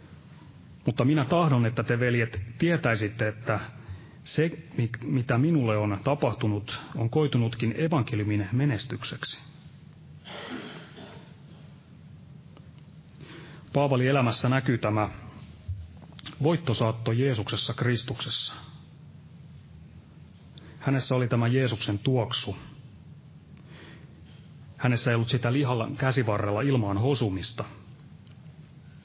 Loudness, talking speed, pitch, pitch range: -27 LUFS, 75 wpm, 130 Hz, 115-145 Hz